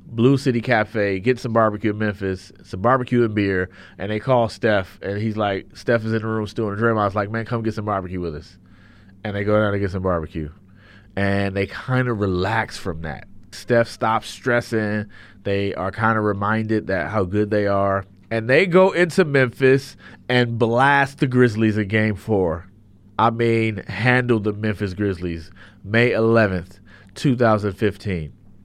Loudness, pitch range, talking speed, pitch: -20 LUFS, 100-115 Hz, 180 wpm, 105 Hz